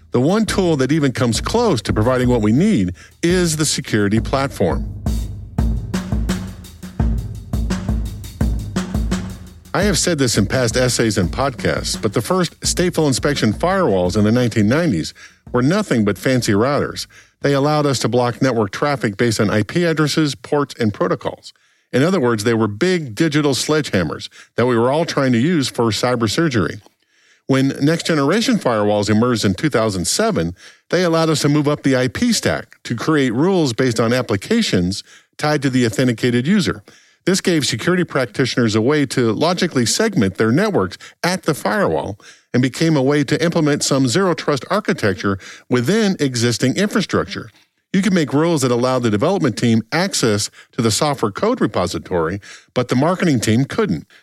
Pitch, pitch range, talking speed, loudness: 130 Hz, 110-160 Hz, 160 wpm, -17 LUFS